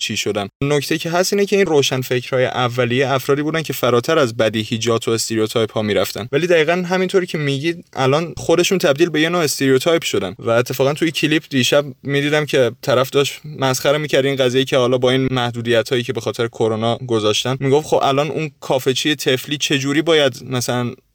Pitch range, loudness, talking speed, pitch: 125-150 Hz, -17 LUFS, 195 wpm, 135 Hz